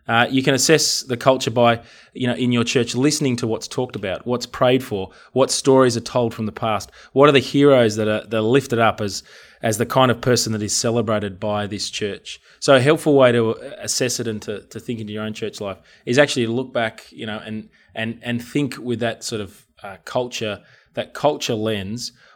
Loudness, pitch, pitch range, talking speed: -19 LUFS, 120 Hz, 110-130 Hz, 230 wpm